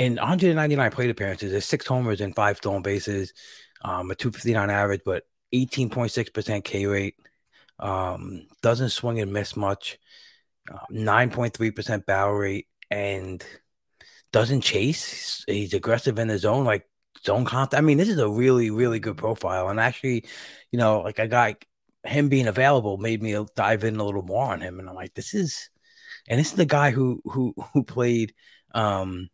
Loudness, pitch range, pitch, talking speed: -24 LUFS, 100-125 Hz, 110 Hz, 170 wpm